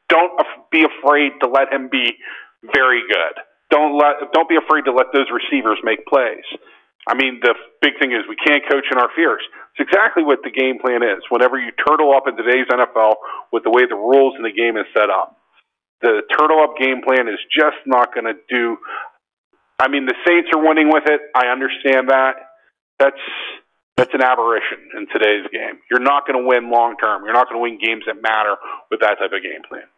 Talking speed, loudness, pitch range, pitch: 215 wpm, -16 LUFS, 125-150 Hz, 135 Hz